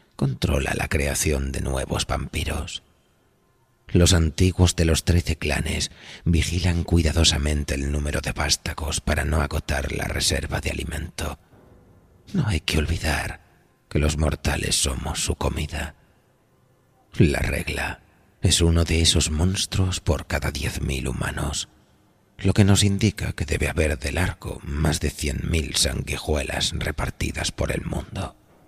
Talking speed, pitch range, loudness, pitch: 135 wpm, 75-95 Hz, -23 LUFS, 85 Hz